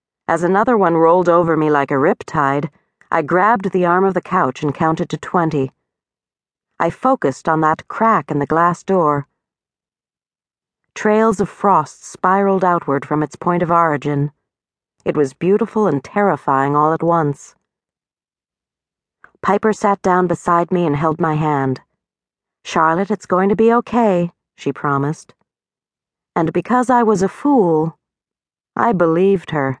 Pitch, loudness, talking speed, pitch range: 170 Hz, -16 LUFS, 145 wpm, 150-195 Hz